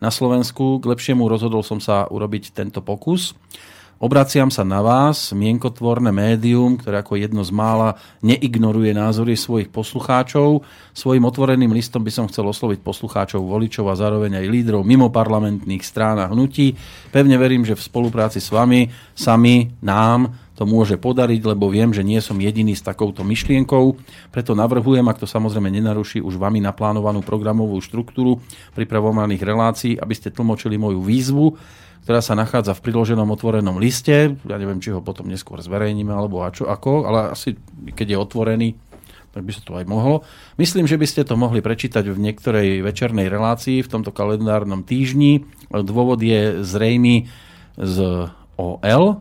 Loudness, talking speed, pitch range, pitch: -18 LUFS, 160 wpm, 100-120 Hz, 110 Hz